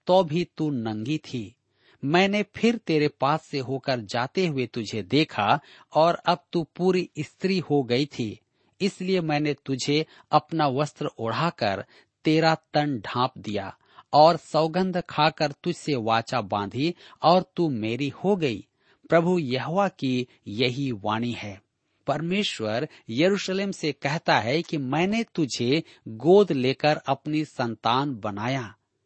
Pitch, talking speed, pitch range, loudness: 150 Hz, 125 wpm, 125-170 Hz, -25 LUFS